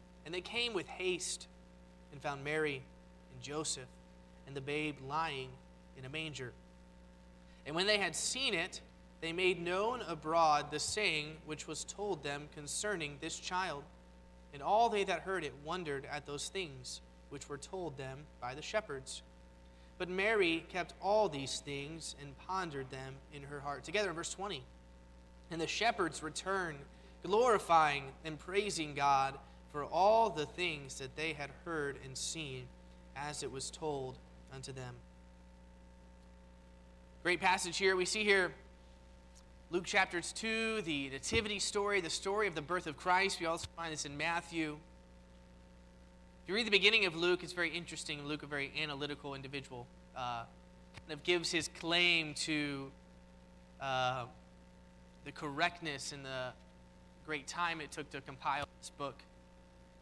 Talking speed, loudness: 155 wpm, -36 LUFS